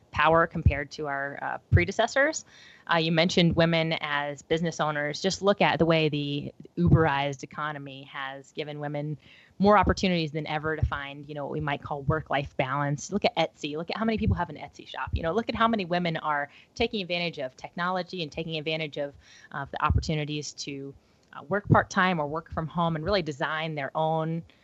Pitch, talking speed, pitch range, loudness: 155 Hz, 200 wpm, 145-170 Hz, -27 LUFS